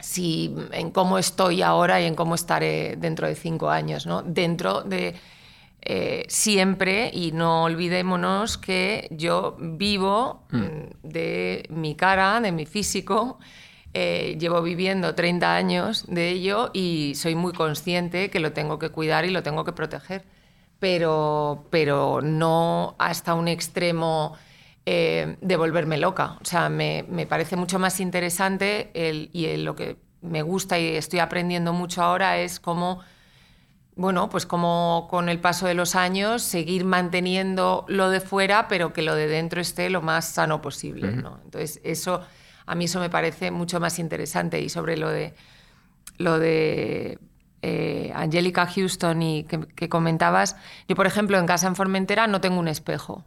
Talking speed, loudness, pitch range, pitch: 160 wpm, -24 LUFS, 160-185 Hz, 175 Hz